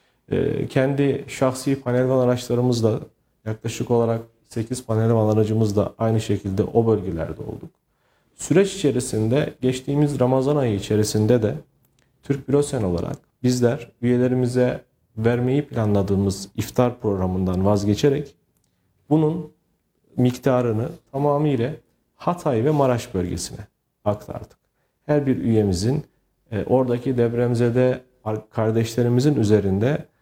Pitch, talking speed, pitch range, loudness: 120 Hz, 90 wpm, 110-135 Hz, -22 LUFS